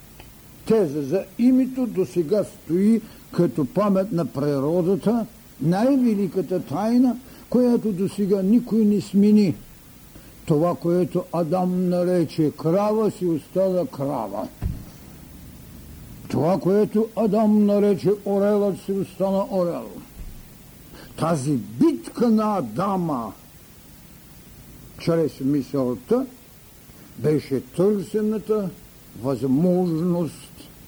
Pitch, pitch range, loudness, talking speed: 190 Hz, 165-210 Hz, -22 LUFS, 85 wpm